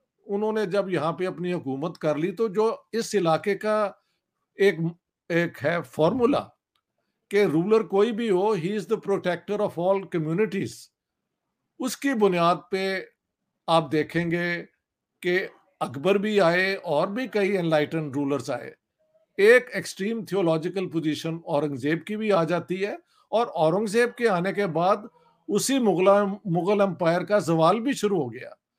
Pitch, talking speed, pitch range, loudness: 195 Hz, 150 wpm, 170-210 Hz, -25 LUFS